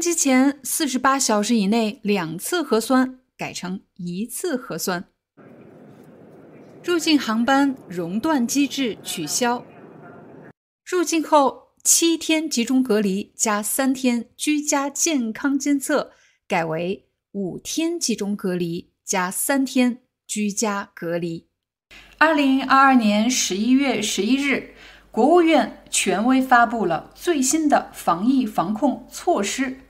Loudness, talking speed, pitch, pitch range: -21 LUFS, 180 characters per minute, 255 Hz, 210-280 Hz